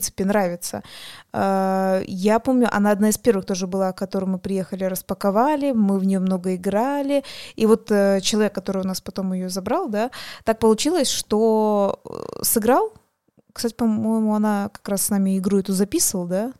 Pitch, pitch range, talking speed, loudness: 205 Hz, 195-225 Hz, 165 wpm, -21 LUFS